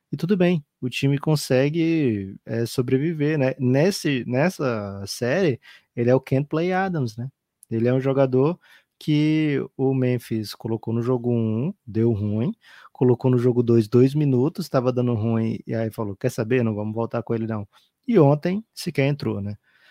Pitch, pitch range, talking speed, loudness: 130 Hz, 115-150 Hz, 175 wpm, -22 LUFS